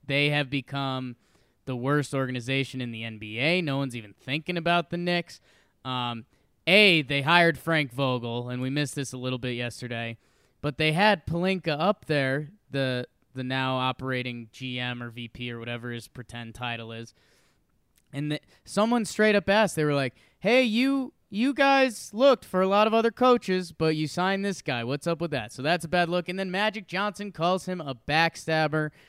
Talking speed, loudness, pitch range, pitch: 190 wpm, -26 LUFS, 125-185 Hz, 145 Hz